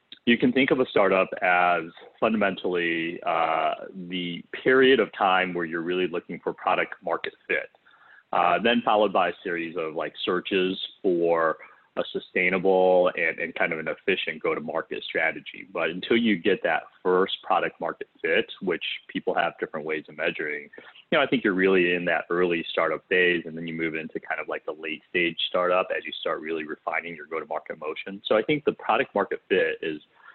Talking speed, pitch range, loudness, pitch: 190 wpm, 85-100 Hz, -25 LUFS, 90 Hz